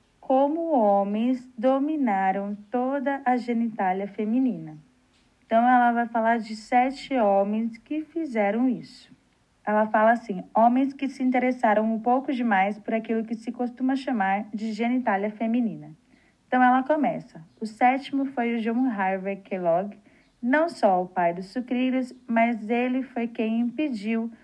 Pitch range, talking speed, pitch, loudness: 210-255 Hz, 140 wpm, 235 Hz, -25 LUFS